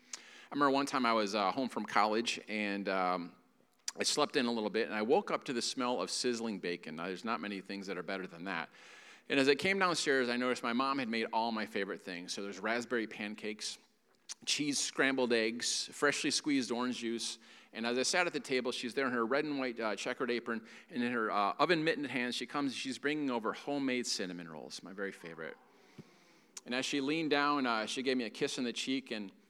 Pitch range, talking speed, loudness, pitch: 105-140 Hz, 230 wpm, -34 LUFS, 120 Hz